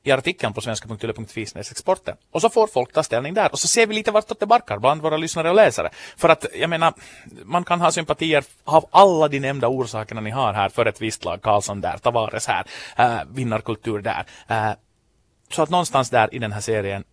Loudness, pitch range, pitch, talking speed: -20 LUFS, 110-165 Hz, 130 Hz, 210 wpm